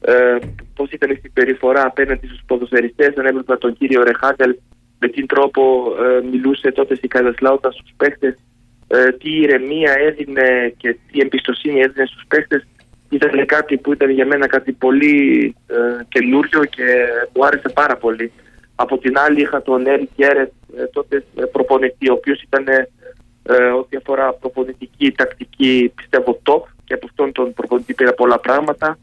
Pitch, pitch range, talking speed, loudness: 130 Hz, 125-140 Hz, 155 wpm, -15 LUFS